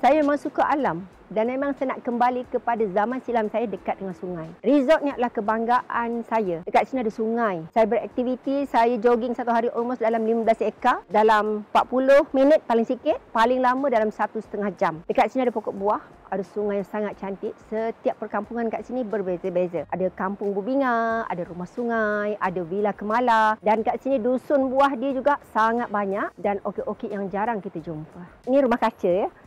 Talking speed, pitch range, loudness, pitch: 185 wpm, 205-250 Hz, -24 LUFS, 225 Hz